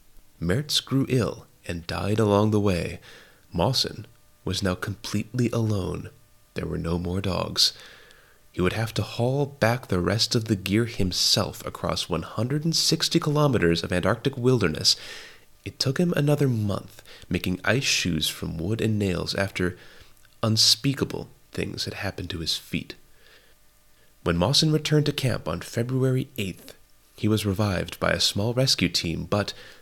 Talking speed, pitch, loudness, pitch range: 155 wpm, 105 Hz, -24 LUFS, 95-130 Hz